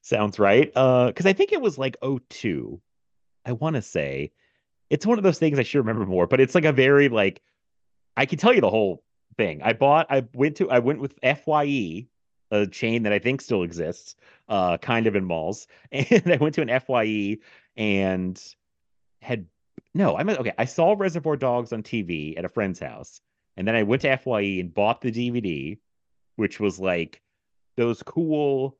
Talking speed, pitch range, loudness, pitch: 200 wpm, 105-150 Hz, -23 LUFS, 125 Hz